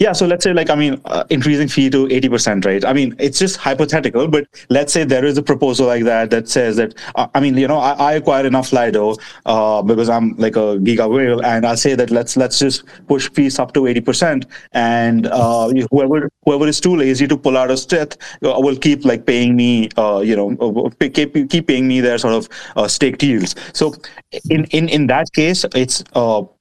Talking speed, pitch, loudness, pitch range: 220 wpm, 135 Hz, -15 LUFS, 120-150 Hz